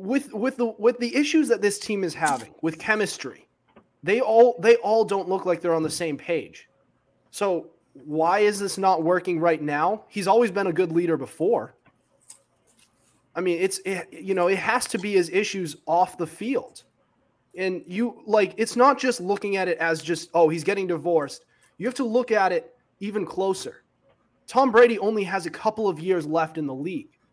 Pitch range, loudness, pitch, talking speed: 170-225 Hz, -23 LUFS, 195 Hz, 200 wpm